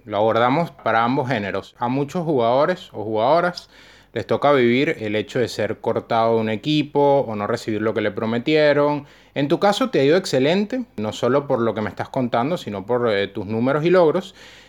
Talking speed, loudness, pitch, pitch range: 205 wpm, -20 LUFS, 120 Hz, 110-145 Hz